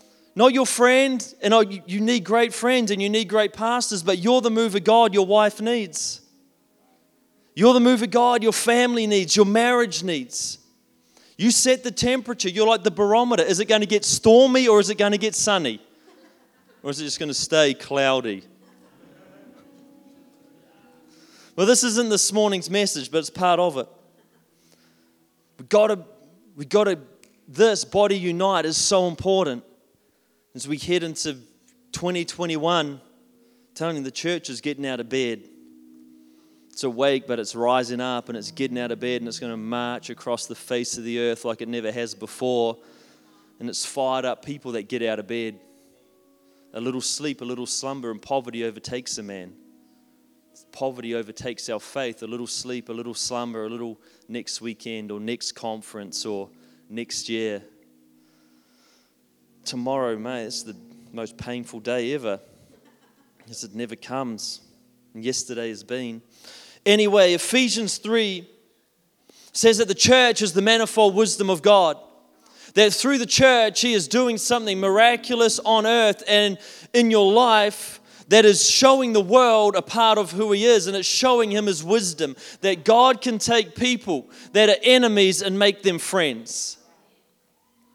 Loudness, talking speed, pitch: -20 LUFS, 165 wpm, 180 Hz